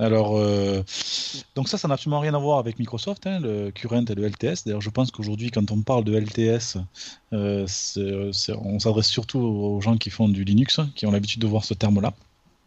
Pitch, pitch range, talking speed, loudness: 110 Hz, 105-120 Hz, 225 wpm, -24 LUFS